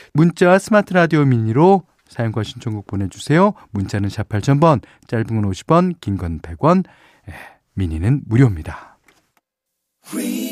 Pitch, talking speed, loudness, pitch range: 120 Hz, 245 characters per minute, -17 LUFS, 100-165 Hz